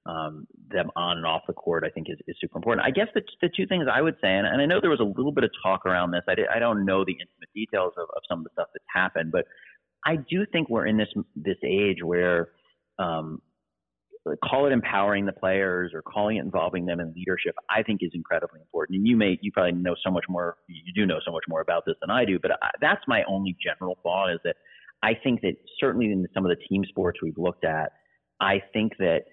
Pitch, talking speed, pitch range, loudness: 95 Hz, 255 wpm, 85-110 Hz, -26 LUFS